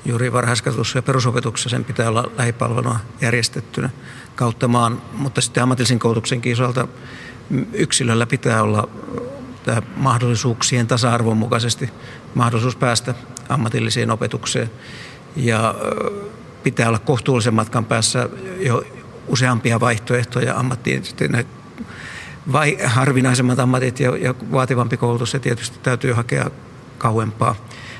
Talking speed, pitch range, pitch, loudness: 105 wpm, 120-130 Hz, 120 Hz, -19 LUFS